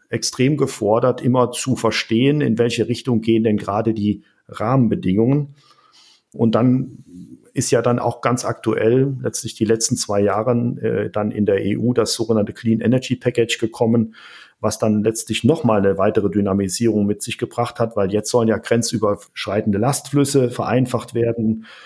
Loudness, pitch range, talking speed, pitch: -19 LUFS, 110-125 Hz, 155 wpm, 115 Hz